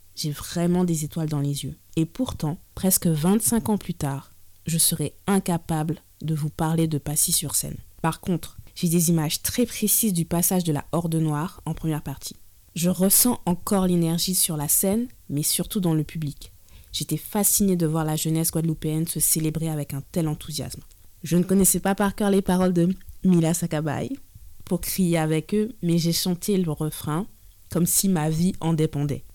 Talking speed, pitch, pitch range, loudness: 185 wpm, 165 Hz, 150-180 Hz, -23 LUFS